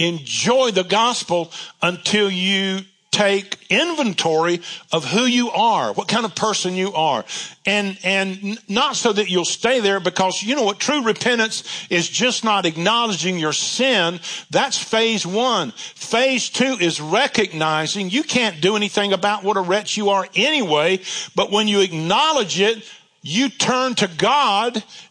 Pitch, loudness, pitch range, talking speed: 205 Hz, -18 LUFS, 185-230 Hz, 155 wpm